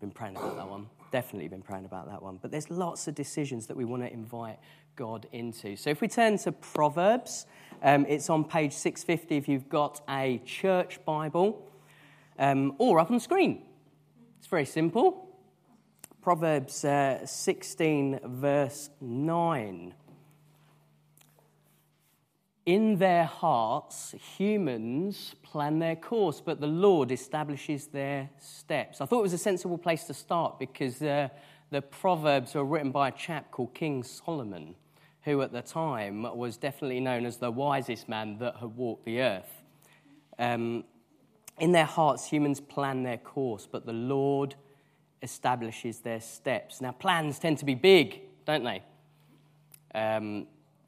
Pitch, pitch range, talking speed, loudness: 145 Hz, 125-160 Hz, 150 wpm, -30 LUFS